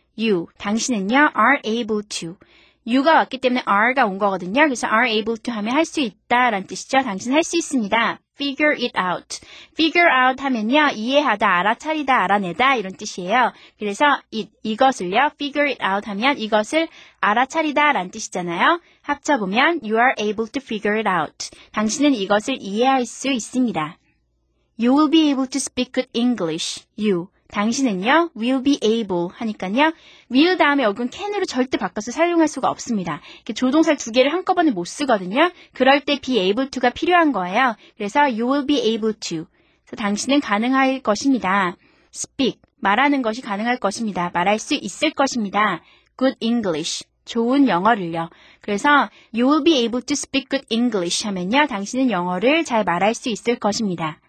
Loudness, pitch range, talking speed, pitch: -19 LUFS, 210-285 Hz, 470 characters per minute, 245 Hz